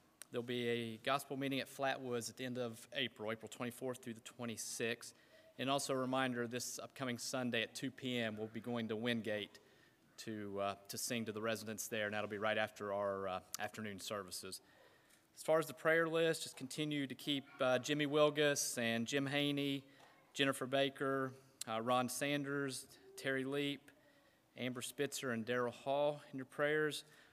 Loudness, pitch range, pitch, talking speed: -40 LUFS, 115-140 Hz, 125 Hz, 175 wpm